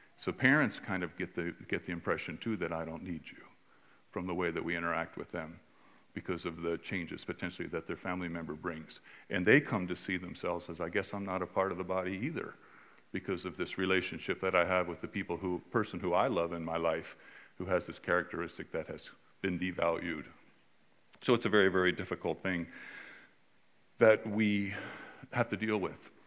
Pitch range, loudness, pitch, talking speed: 85-95 Hz, -34 LUFS, 90 Hz, 205 wpm